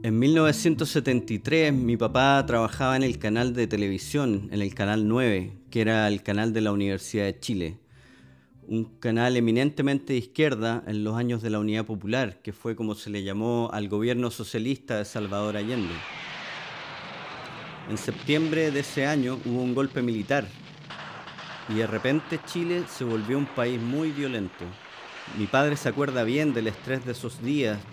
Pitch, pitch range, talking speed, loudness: 120 Hz, 110-140 Hz, 165 wpm, -26 LUFS